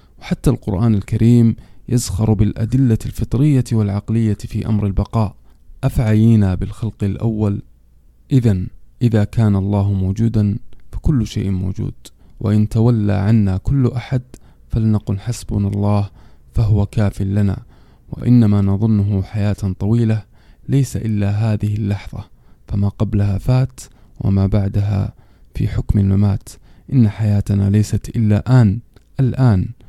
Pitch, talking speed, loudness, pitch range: 105 Hz, 110 wpm, -17 LUFS, 100-115 Hz